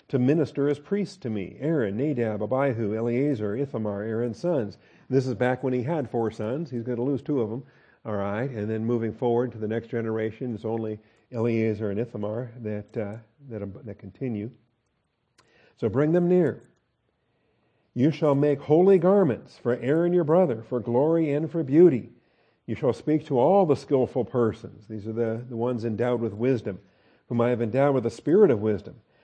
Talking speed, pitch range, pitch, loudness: 190 wpm, 110-140 Hz, 120 Hz, -25 LUFS